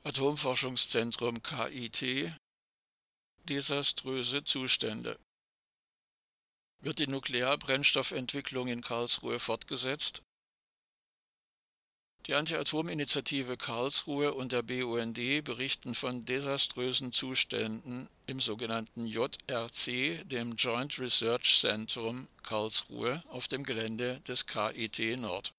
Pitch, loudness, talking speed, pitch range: 125 Hz, -31 LUFS, 80 wpm, 115-135 Hz